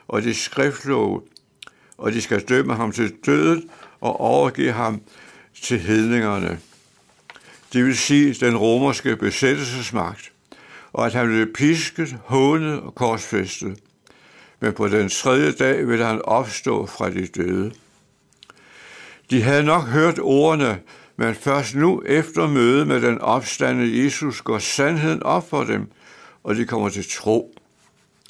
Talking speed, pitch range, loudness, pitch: 135 wpm, 110-140 Hz, -20 LUFS, 120 Hz